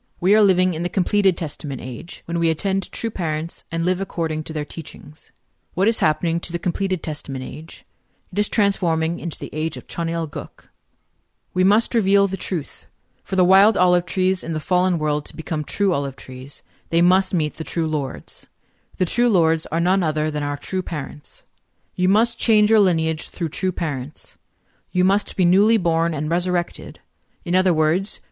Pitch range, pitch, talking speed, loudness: 155-190 Hz, 170 Hz, 190 wpm, -21 LUFS